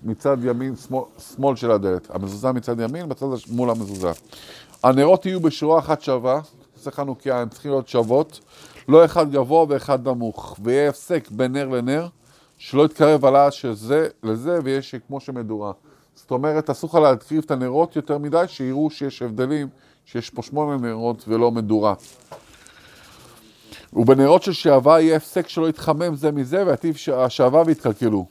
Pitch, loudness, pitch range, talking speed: 135 Hz, -20 LUFS, 120-155 Hz, 155 wpm